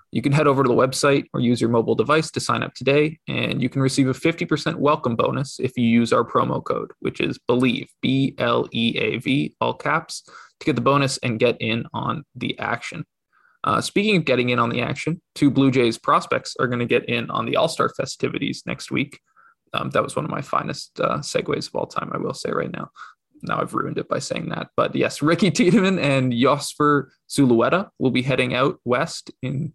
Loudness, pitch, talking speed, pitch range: -21 LUFS, 130 Hz, 220 wpm, 120-150 Hz